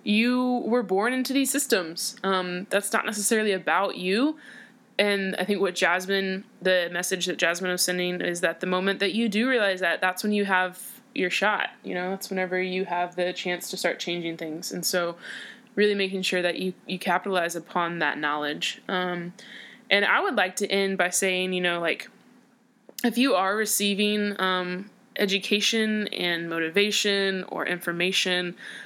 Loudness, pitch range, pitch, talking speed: -25 LUFS, 180-210 Hz, 190 Hz, 175 wpm